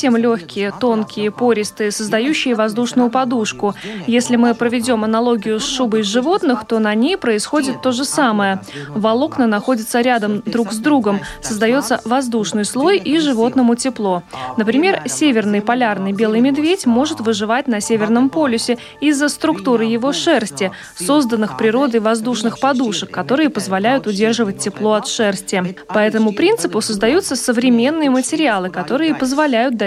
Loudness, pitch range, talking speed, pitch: -16 LUFS, 215-265 Hz, 130 wpm, 235 Hz